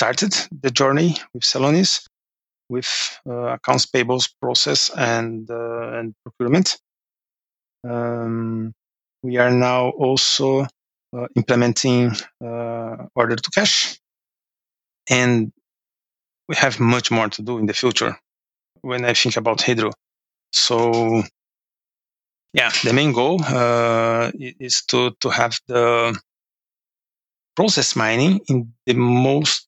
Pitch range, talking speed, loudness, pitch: 115-130 Hz, 115 wpm, -19 LUFS, 120 Hz